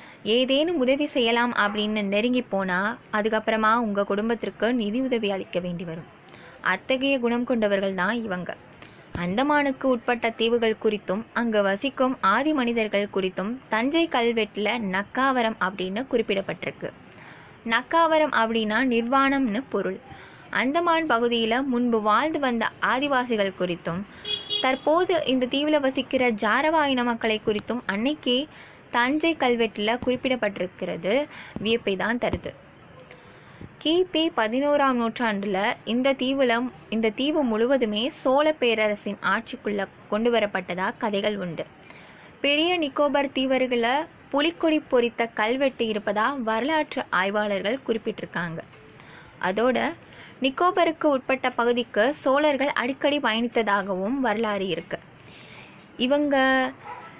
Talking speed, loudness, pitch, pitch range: 95 wpm, -24 LUFS, 235 Hz, 210-270 Hz